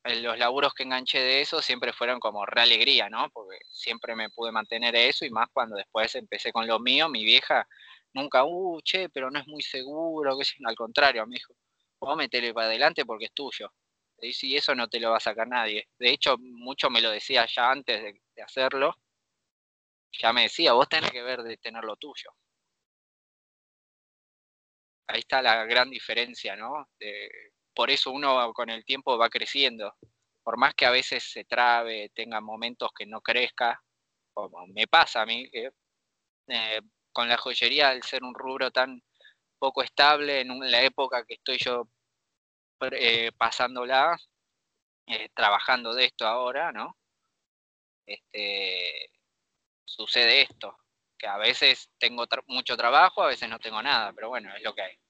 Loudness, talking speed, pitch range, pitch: -25 LUFS, 170 wpm, 115-135 Hz, 120 Hz